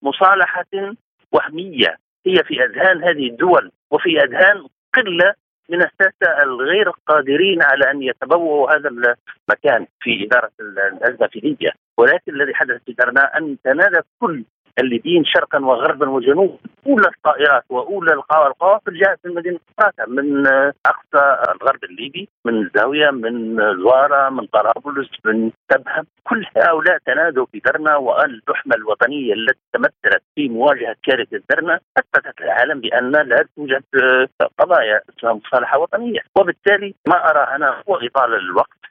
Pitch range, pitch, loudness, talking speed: 135-195 Hz, 155 Hz, -16 LUFS, 130 wpm